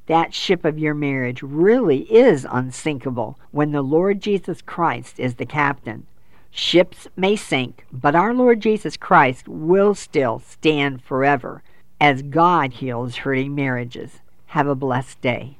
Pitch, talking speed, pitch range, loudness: 140 Hz, 140 wpm, 125-165 Hz, -19 LUFS